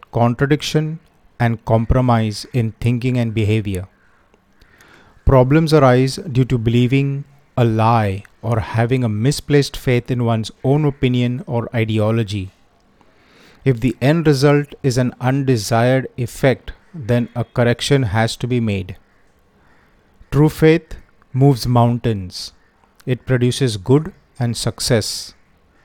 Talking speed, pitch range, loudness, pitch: 115 wpm, 110-135 Hz, -17 LUFS, 120 Hz